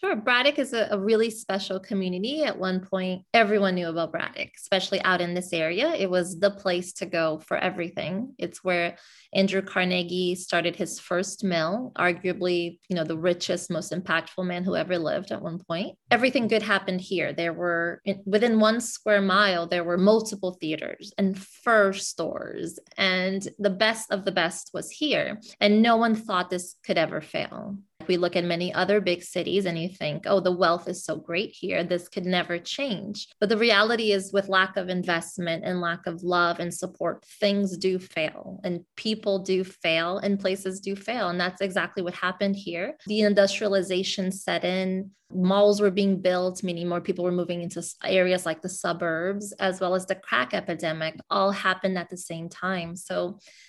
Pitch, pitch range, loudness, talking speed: 185 Hz, 175-200 Hz, -26 LUFS, 185 wpm